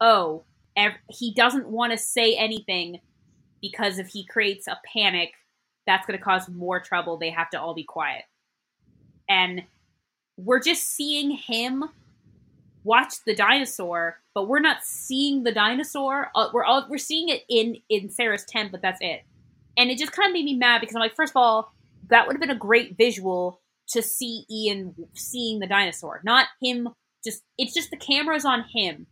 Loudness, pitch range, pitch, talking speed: -23 LUFS, 185-255 Hz, 225 Hz, 175 wpm